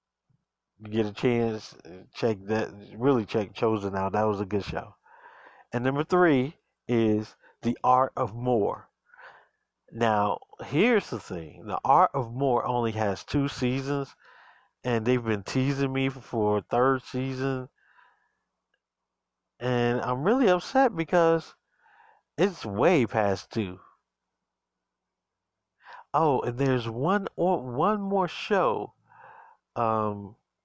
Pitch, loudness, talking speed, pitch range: 125 Hz, -27 LUFS, 115 wpm, 110-140 Hz